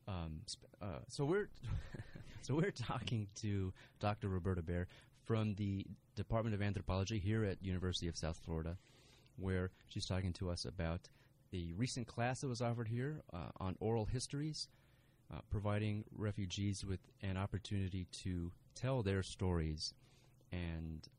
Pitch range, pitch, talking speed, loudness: 95-125 Hz, 105 Hz, 140 wpm, -42 LUFS